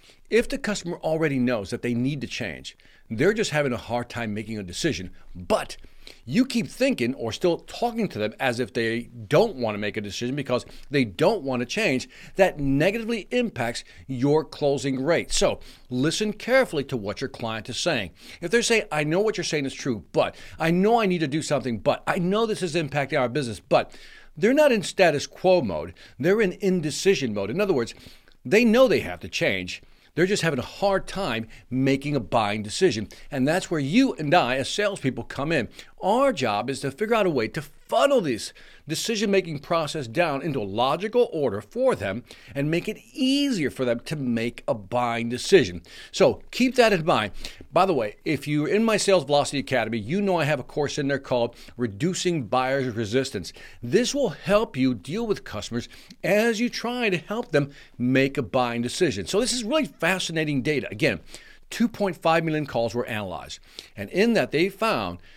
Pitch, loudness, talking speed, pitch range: 150 Hz, -24 LUFS, 195 wpm, 125-195 Hz